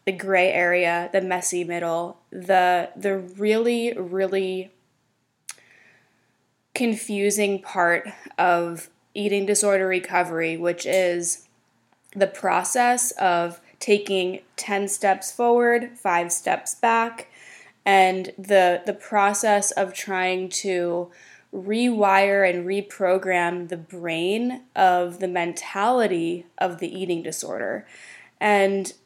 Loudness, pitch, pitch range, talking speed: -22 LUFS, 190 Hz, 175-205 Hz, 100 wpm